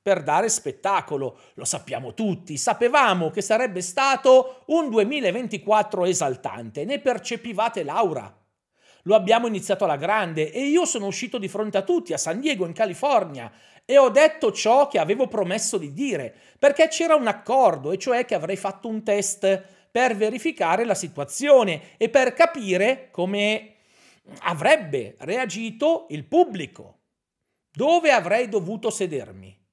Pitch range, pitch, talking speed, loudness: 190-260 Hz, 220 Hz, 140 wpm, -22 LUFS